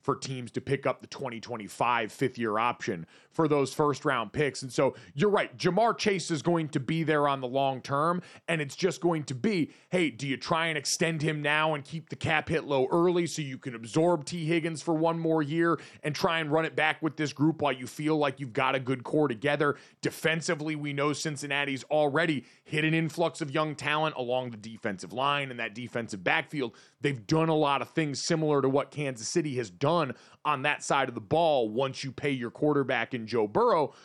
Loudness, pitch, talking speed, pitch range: -29 LUFS, 145 Hz, 220 wpm, 135-160 Hz